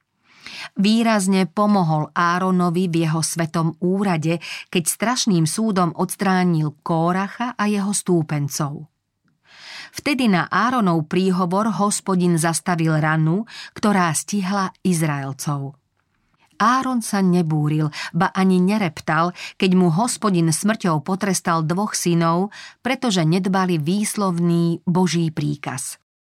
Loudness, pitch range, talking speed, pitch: -20 LUFS, 165-200 Hz, 100 wpm, 180 Hz